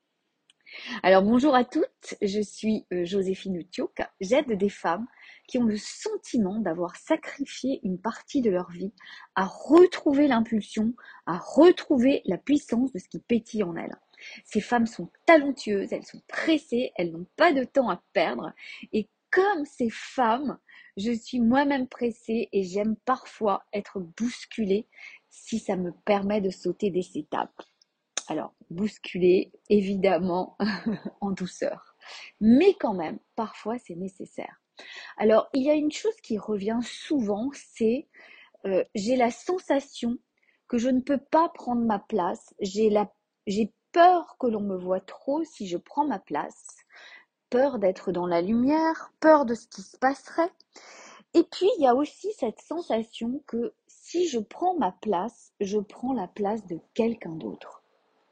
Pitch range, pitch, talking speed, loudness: 200-280 Hz, 230 Hz, 155 wpm, -26 LUFS